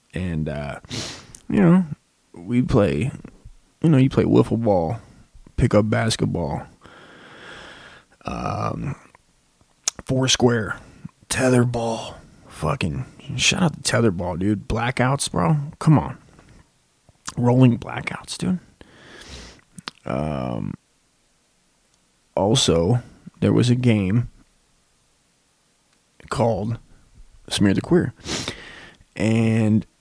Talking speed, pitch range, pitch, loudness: 90 wpm, 100-130 Hz, 115 Hz, -21 LUFS